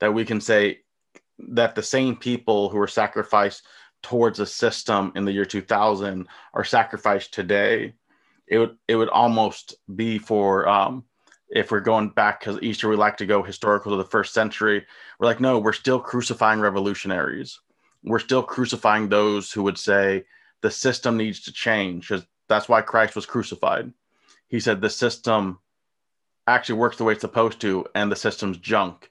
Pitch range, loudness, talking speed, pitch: 100-115 Hz, -22 LUFS, 175 wpm, 105 Hz